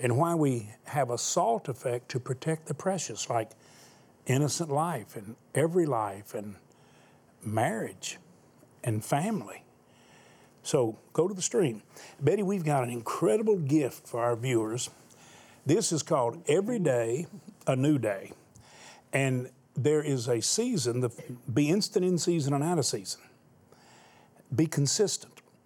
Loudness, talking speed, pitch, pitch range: -29 LUFS, 140 wpm, 140 Hz, 120-170 Hz